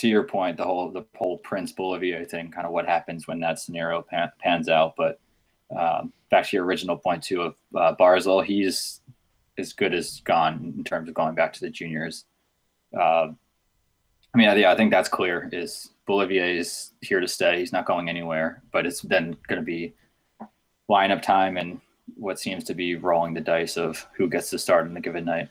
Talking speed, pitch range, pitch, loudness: 205 wpm, 85-95 Hz, 85 Hz, -24 LUFS